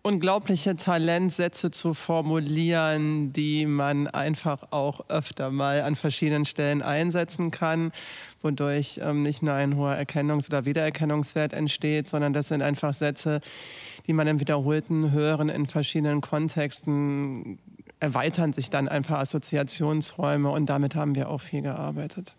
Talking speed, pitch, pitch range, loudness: 130 wpm, 150 Hz, 145-155 Hz, -26 LUFS